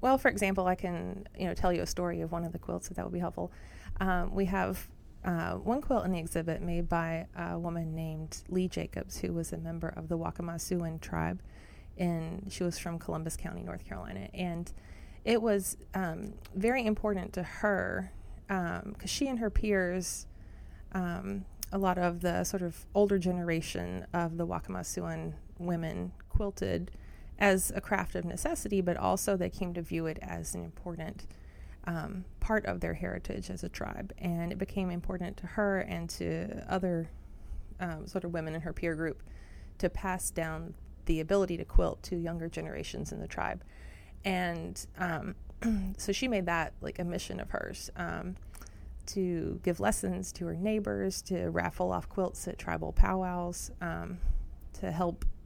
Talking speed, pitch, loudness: 175 wpm, 170 Hz, -34 LUFS